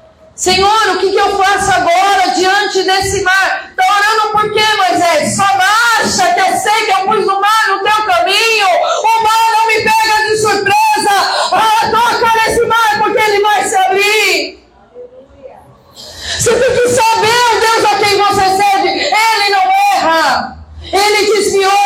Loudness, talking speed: -10 LUFS, 160 wpm